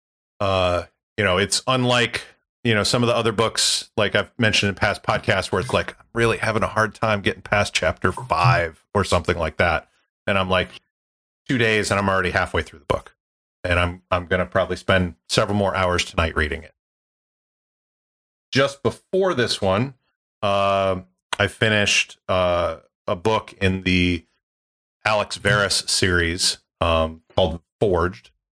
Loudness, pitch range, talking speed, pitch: -21 LUFS, 90-110 Hz, 160 wpm, 95 Hz